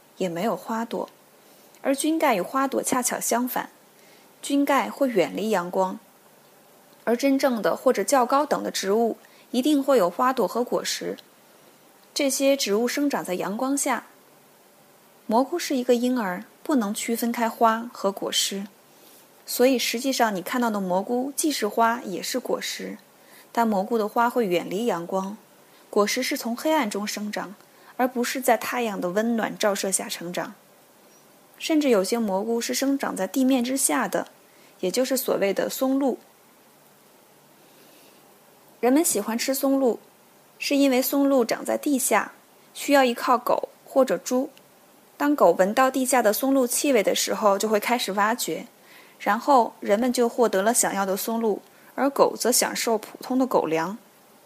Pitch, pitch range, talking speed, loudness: 235 Hz, 205-265 Hz, 230 characters per minute, -24 LUFS